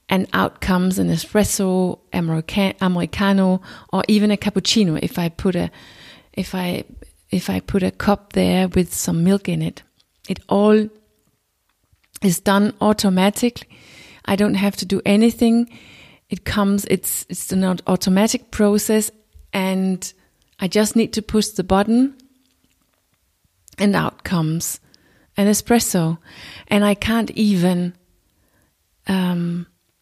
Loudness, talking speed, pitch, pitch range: -19 LUFS, 125 wpm, 190 Hz, 175-210 Hz